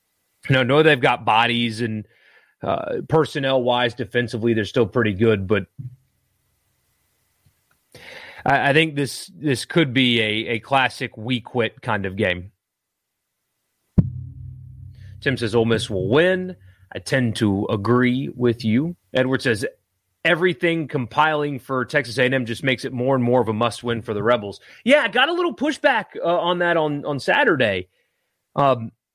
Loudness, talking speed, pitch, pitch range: -20 LUFS, 150 wpm, 125 Hz, 115-145 Hz